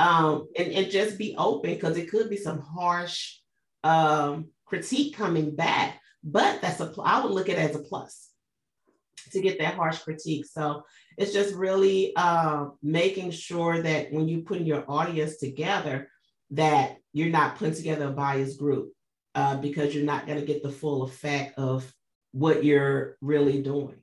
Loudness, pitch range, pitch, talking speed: -27 LUFS, 145-175 Hz, 155 Hz, 175 wpm